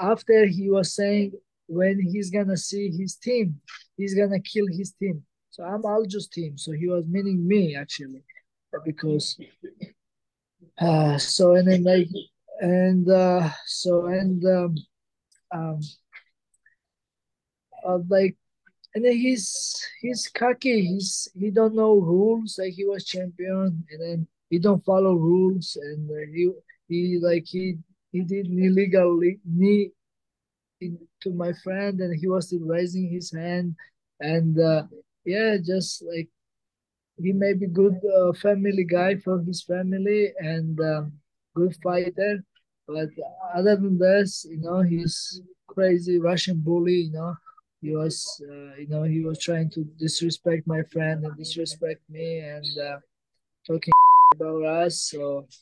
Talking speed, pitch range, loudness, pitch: 140 wpm, 165-195 Hz, -23 LUFS, 180 Hz